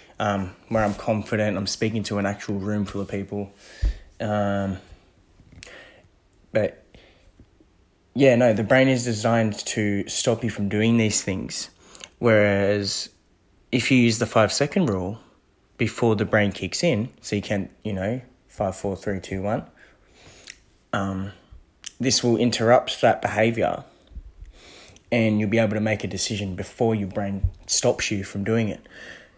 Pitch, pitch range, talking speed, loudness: 105 Hz, 95-115 Hz, 150 wpm, -23 LUFS